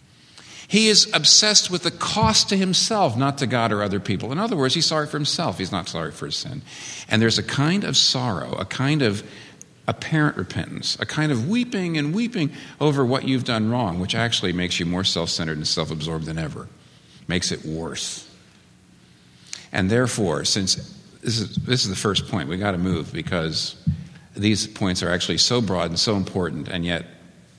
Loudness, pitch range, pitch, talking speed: -21 LUFS, 90-150 Hz, 115 Hz, 195 wpm